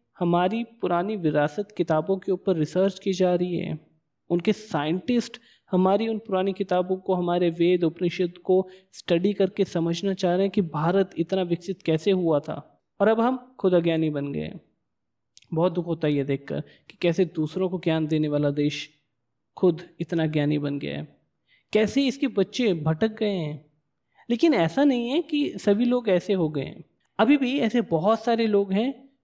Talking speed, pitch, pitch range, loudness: 175 wpm, 185 Hz, 160-205 Hz, -25 LUFS